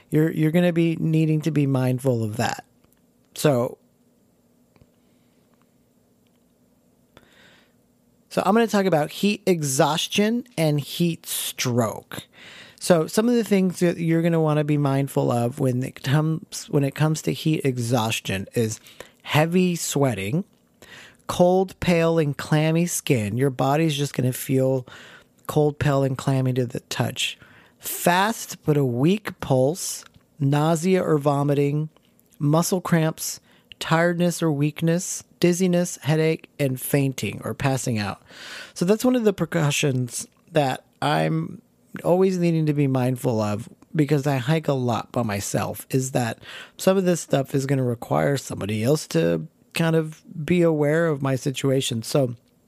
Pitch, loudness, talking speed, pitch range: 150 Hz, -23 LUFS, 145 wpm, 130-170 Hz